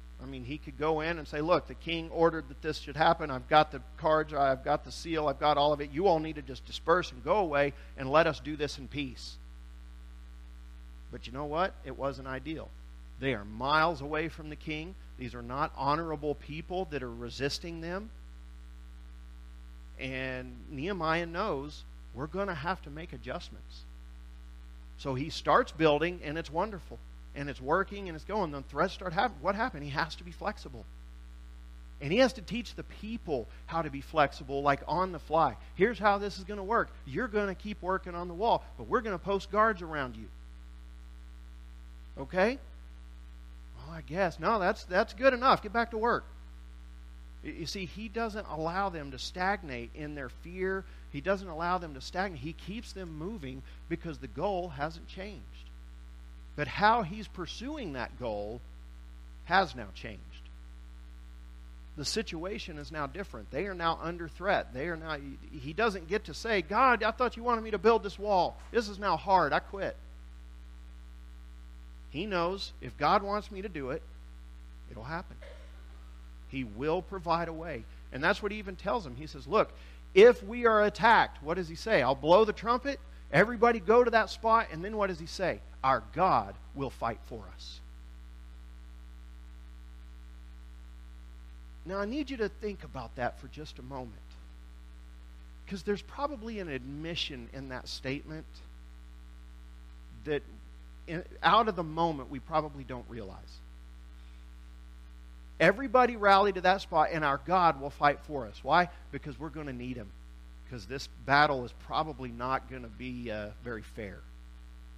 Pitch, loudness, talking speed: 140 Hz, -31 LUFS, 175 wpm